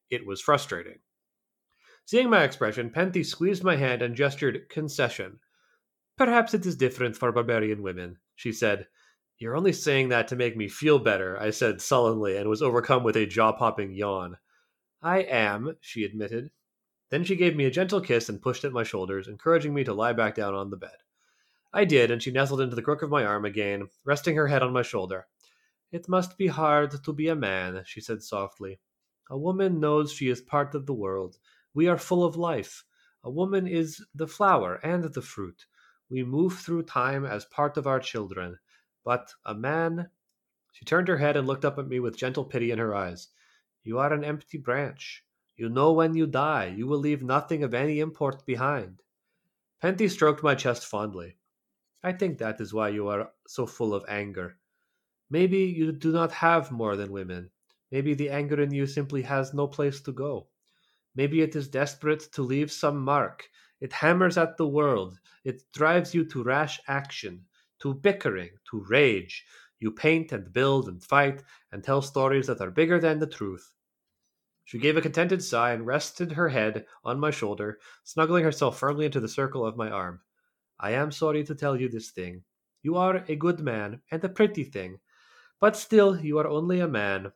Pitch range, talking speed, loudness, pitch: 110-160 Hz, 190 wpm, -27 LUFS, 140 Hz